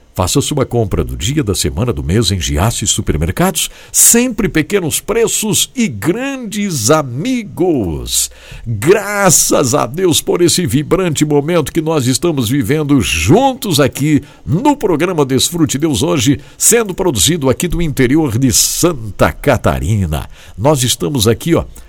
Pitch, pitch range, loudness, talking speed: 145 Hz, 115-175 Hz, -13 LUFS, 135 wpm